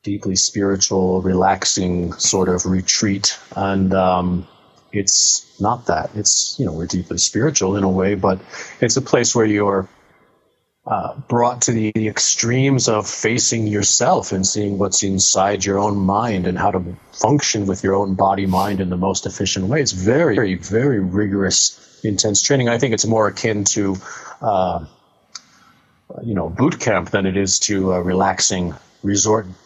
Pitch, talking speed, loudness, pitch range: 100 Hz, 165 wpm, -17 LUFS, 95-110 Hz